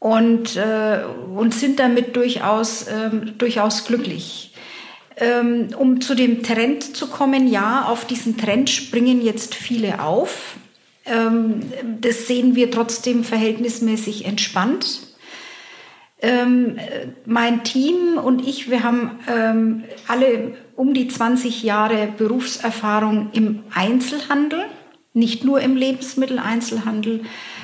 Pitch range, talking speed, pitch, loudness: 225-260 Hz, 110 wpm, 235 Hz, -19 LUFS